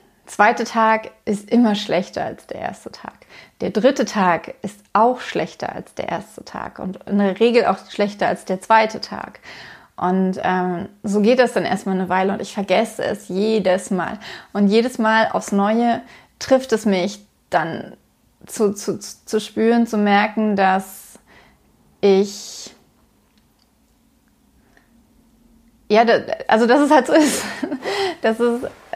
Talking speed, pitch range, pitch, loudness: 145 wpm, 195-235 Hz, 210 Hz, -19 LUFS